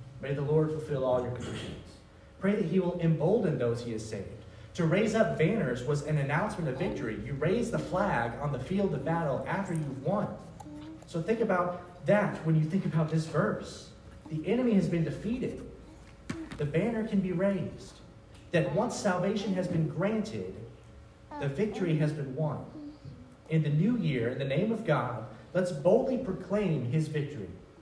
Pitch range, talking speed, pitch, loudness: 140-190 Hz, 175 wpm, 160 Hz, -31 LUFS